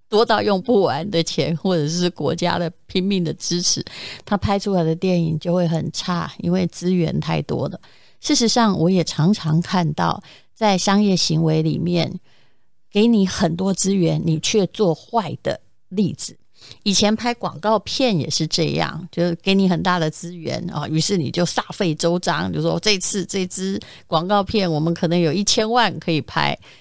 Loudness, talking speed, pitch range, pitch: -20 LUFS, 255 characters per minute, 165-200 Hz, 175 Hz